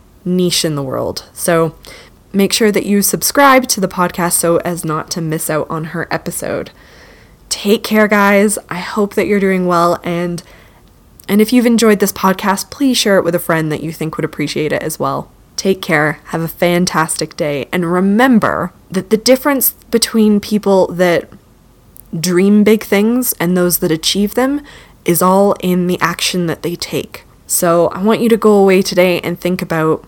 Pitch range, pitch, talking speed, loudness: 170-205 Hz, 180 Hz, 185 wpm, -13 LUFS